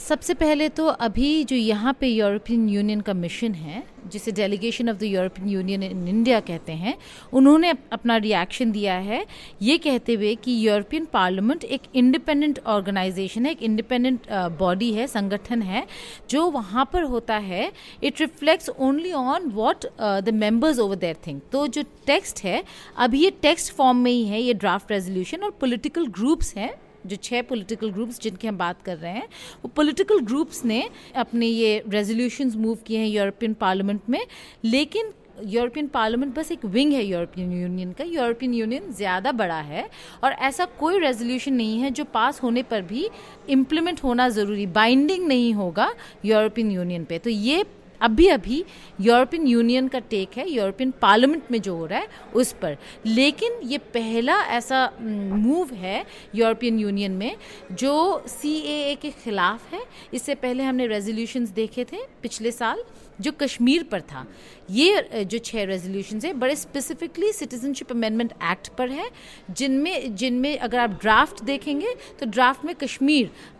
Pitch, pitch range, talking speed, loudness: 240 Hz, 210-280 Hz, 165 wpm, -23 LUFS